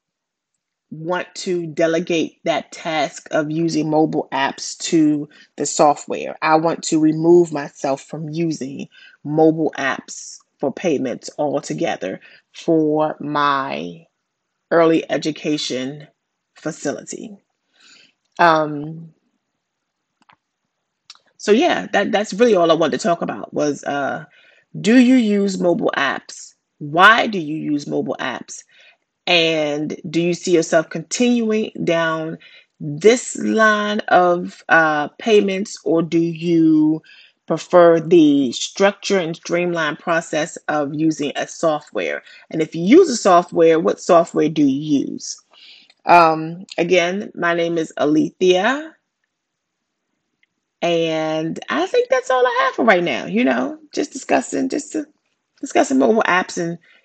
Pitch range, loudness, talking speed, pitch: 155-200 Hz, -18 LUFS, 120 wpm, 165 Hz